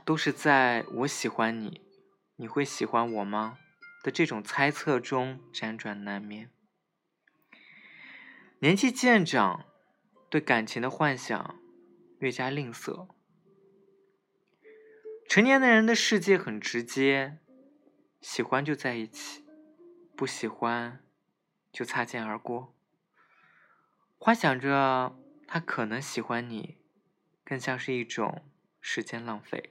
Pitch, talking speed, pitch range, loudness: 140 Hz, 160 characters per minute, 120-195 Hz, -28 LUFS